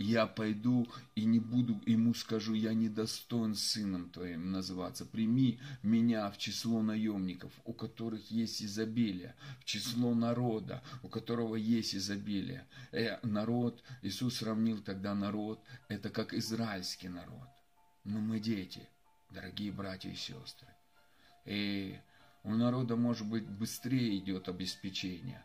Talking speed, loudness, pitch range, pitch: 125 wpm, -36 LUFS, 100-115 Hz, 110 Hz